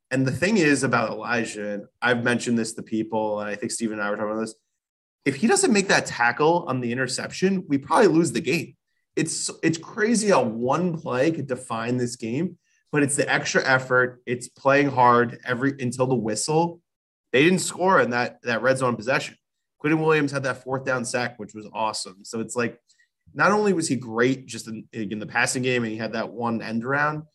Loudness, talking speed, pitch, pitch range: -23 LUFS, 215 wpm, 125 Hz, 115-150 Hz